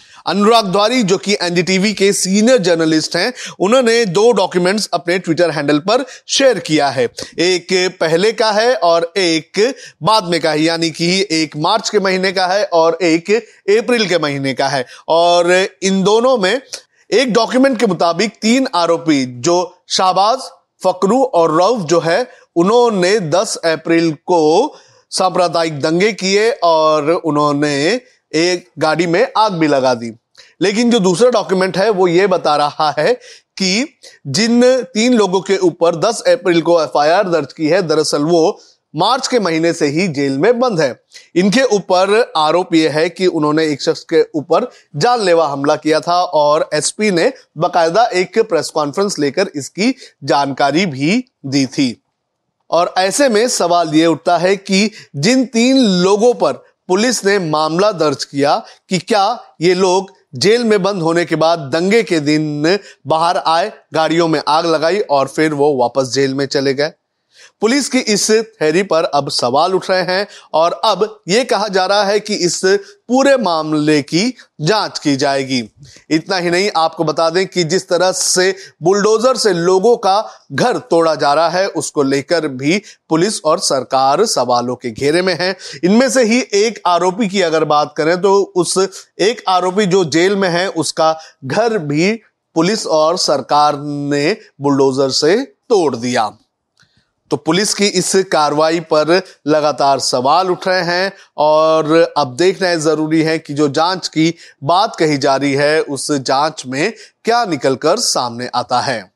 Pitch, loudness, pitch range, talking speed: 175 Hz, -14 LUFS, 155-205 Hz, 165 wpm